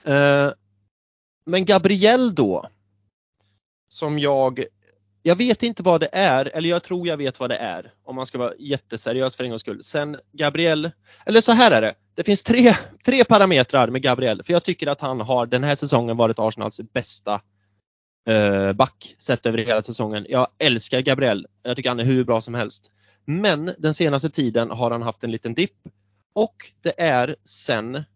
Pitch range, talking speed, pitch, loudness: 110-160 Hz, 180 wpm, 130 Hz, -20 LUFS